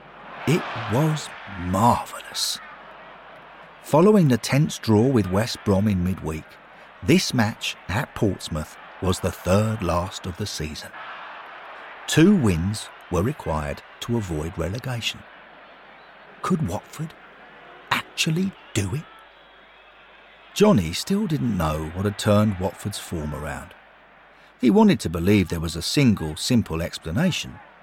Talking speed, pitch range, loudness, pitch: 120 wpm, 85-125 Hz, -23 LUFS, 105 Hz